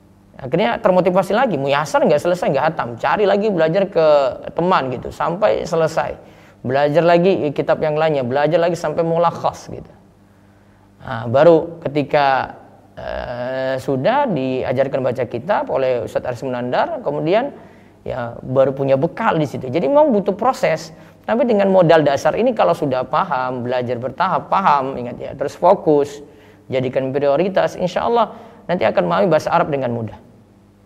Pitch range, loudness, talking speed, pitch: 130-180 Hz, -17 LUFS, 150 wpm, 155 Hz